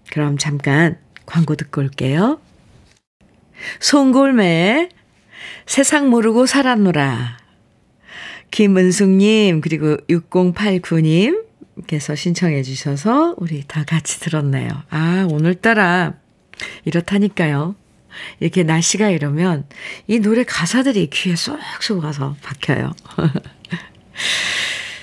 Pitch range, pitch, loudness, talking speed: 150-210 Hz, 170 Hz, -17 LUFS, 200 characters per minute